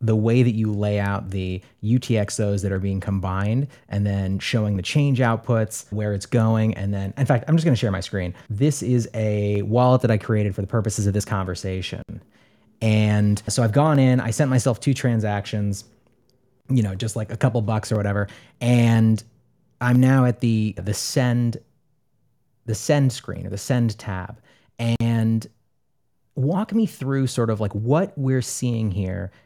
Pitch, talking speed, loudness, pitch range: 115 Hz, 180 wpm, -22 LUFS, 105-125 Hz